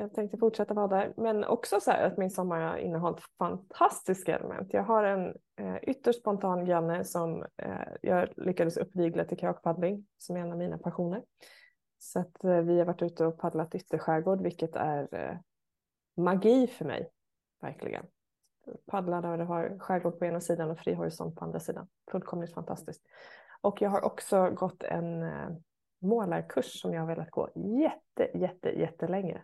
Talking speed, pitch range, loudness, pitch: 175 wpm, 170-200 Hz, -32 LUFS, 175 Hz